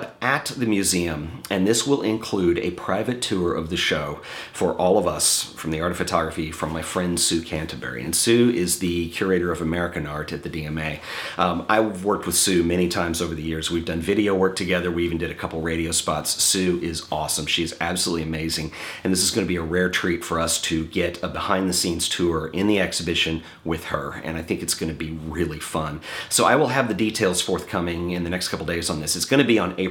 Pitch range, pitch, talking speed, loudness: 80-95 Hz, 85 Hz, 235 wpm, -23 LUFS